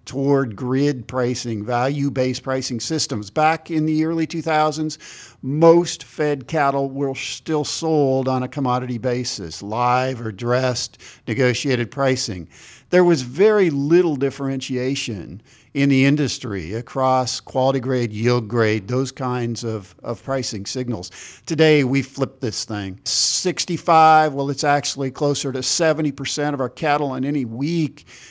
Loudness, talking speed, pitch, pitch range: -20 LUFS, 135 wpm, 130 Hz, 120-145 Hz